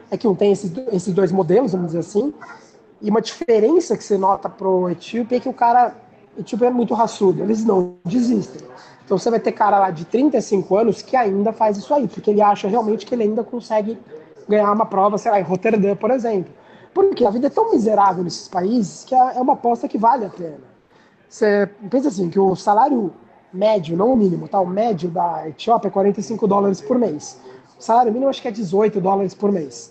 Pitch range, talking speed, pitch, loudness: 195-235 Hz, 215 wpm, 210 Hz, -18 LUFS